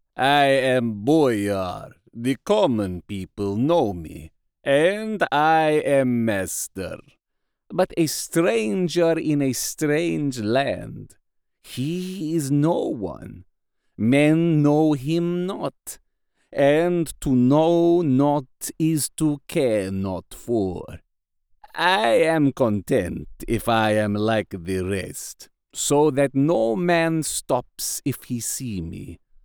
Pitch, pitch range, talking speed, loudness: 140 Hz, 115-160 Hz, 110 wpm, -22 LUFS